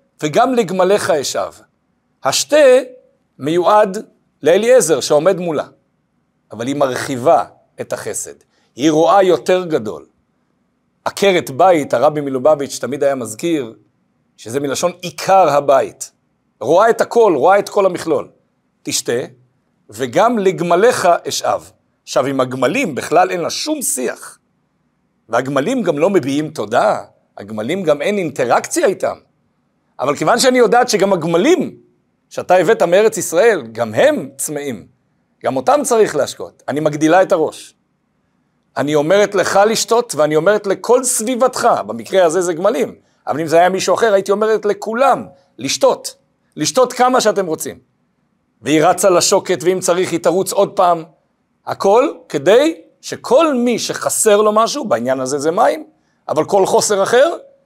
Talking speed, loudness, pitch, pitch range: 135 wpm, -15 LUFS, 190 Hz, 160-225 Hz